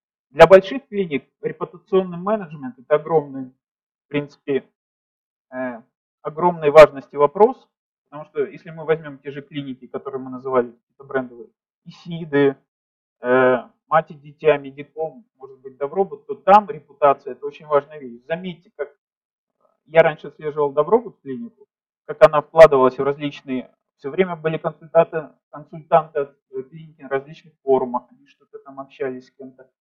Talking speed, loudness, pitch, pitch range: 135 wpm, -19 LUFS, 155 Hz, 135-195 Hz